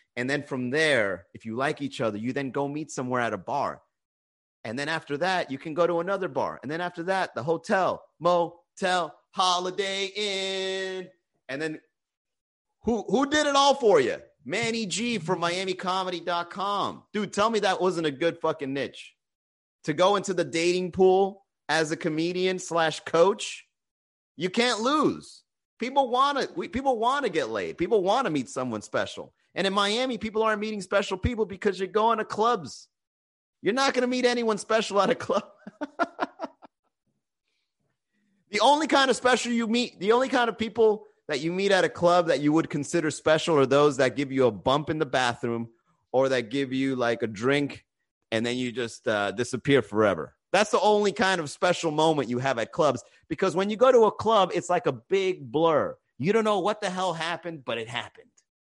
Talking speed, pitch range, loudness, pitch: 190 wpm, 145-220 Hz, -26 LUFS, 185 Hz